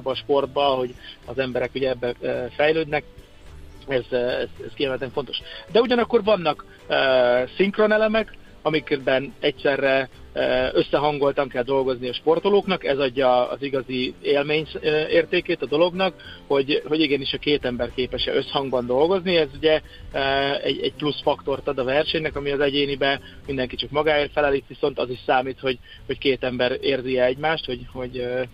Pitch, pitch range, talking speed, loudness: 135 Hz, 125-150 Hz, 150 wpm, -22 LUFS